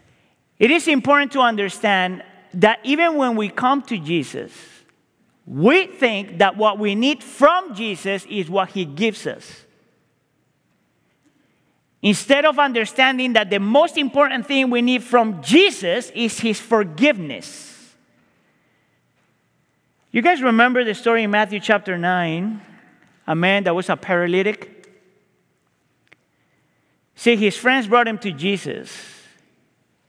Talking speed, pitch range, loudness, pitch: 125 wpm, 200-260 Hz, -18 LUFS, 220 Hz